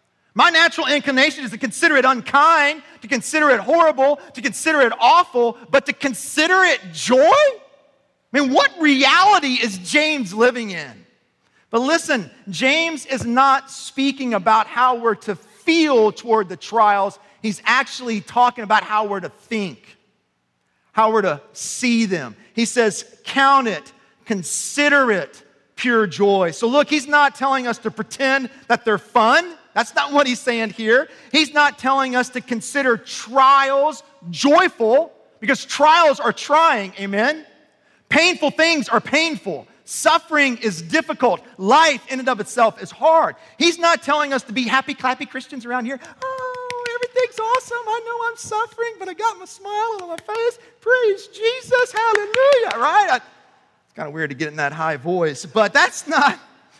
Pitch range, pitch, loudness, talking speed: 220-315 Hz, 270 Hz, -17 LUFS, 160 wpm